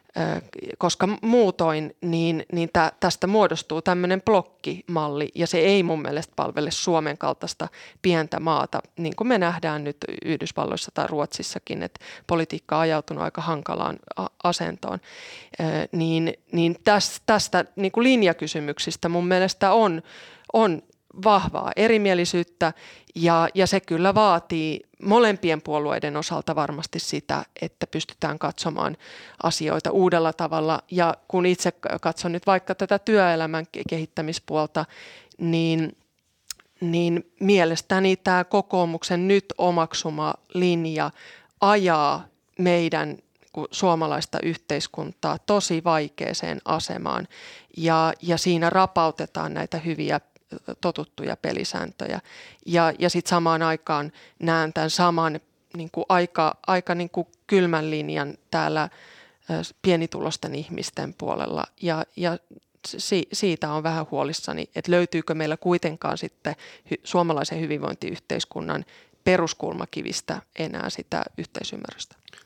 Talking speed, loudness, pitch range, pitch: 110 wpm, -24 LUFS, 160-185 Hz, 170 Hz